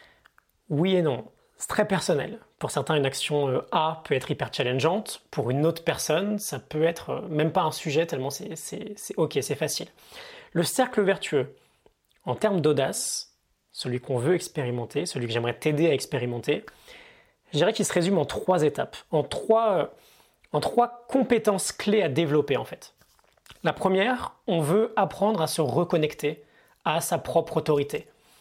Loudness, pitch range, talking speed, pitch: -26 LUFS, 145-200 Hz, 165 wpm, 160 Hz